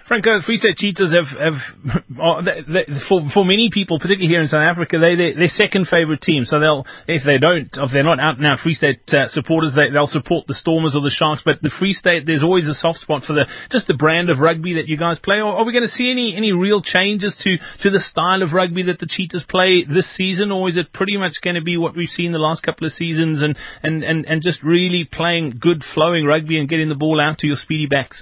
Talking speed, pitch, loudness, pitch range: 265 wpm, 165 Hz, -17 LUFS, 155-185 Hz